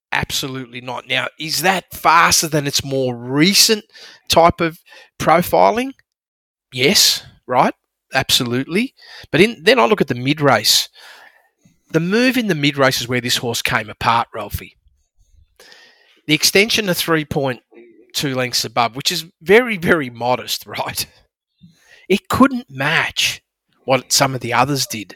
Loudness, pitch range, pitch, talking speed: -16 LUFS, 125-190 Hz, 150 Hz, 140 wpm